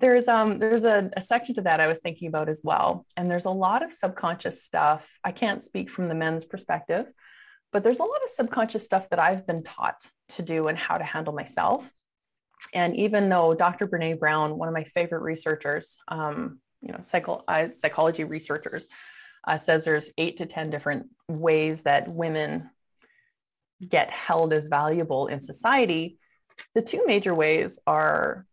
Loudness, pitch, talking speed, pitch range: -25 LUFS, 170 Hz, 180 wpm, 155-205 Hz